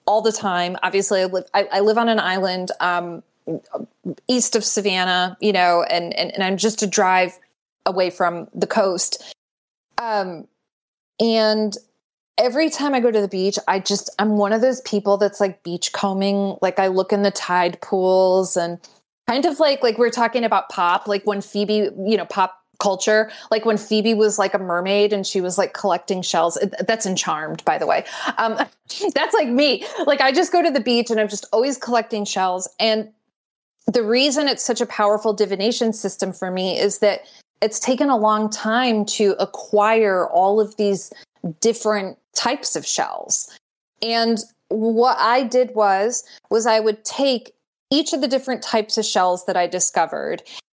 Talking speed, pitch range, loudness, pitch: 180 wpm, 190-230 Hz, -19 LUFS, 210 Hz